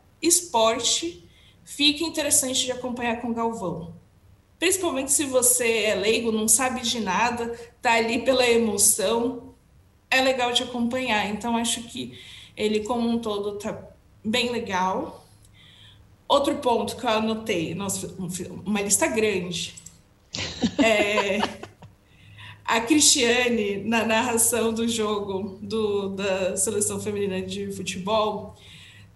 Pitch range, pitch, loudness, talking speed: 195-240 Hz, 225 Hz, -23 LUFS, 115 wpm